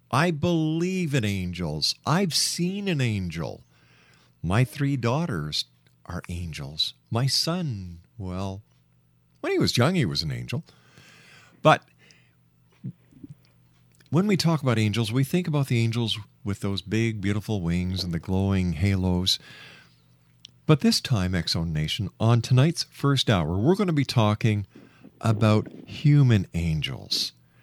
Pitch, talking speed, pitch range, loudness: 105 Hz, 130 wpm, 85-140 Hz, -25 LUFS